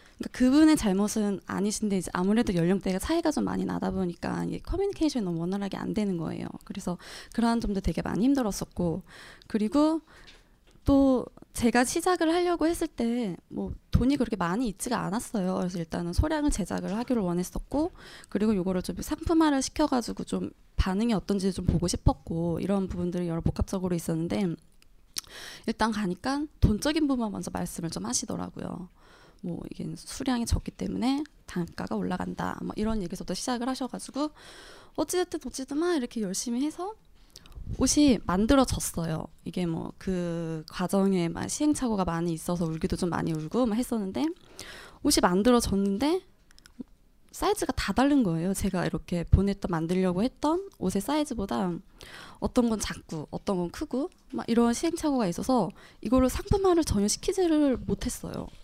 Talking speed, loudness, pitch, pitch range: 360 characters per minute, -28 LUFS, 215 Hz, 180-270 Hz